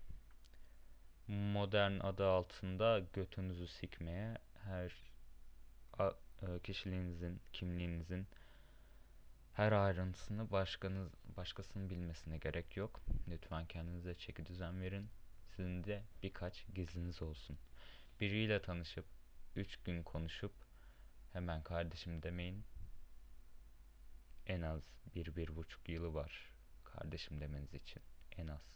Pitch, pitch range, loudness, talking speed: 90 Hz, 80-95 Hz, -44 LUFS, 90 wpm